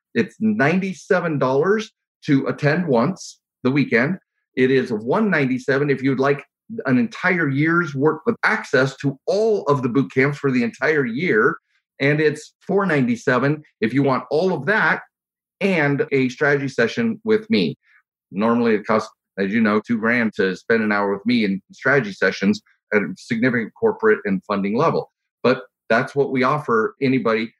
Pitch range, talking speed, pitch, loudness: 130-200 Hz, 160 wpm, 140 Hz, -20 LUFS